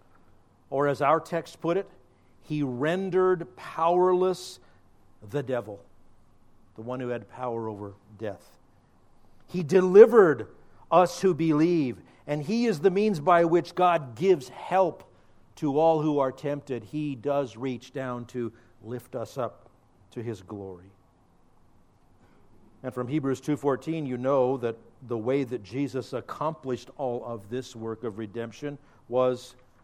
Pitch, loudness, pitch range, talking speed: 125 Hz, -26 LUFS, 110-155 Hz, 135 wpm